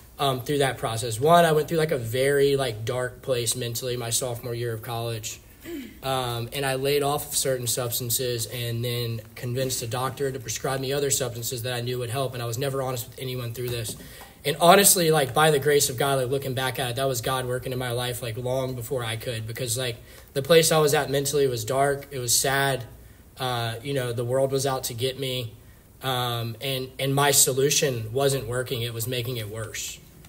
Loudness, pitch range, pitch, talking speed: -25 LUFS, 120-140 Hz, 130 Hz, 220 wpm